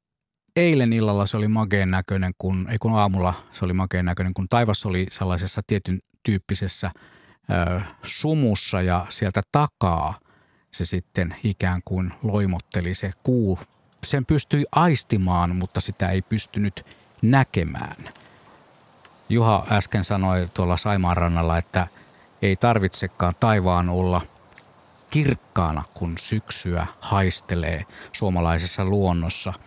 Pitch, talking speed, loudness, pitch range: 95 Hz, 115 wpm, -23 LUFS, 90-110 Hz